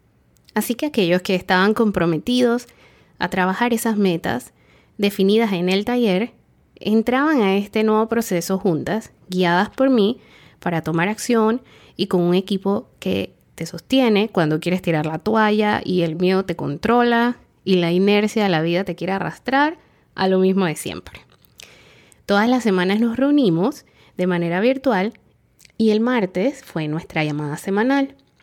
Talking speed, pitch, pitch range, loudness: 150 wpm, 200 Hz, 180-230 Hz, -19 LUFS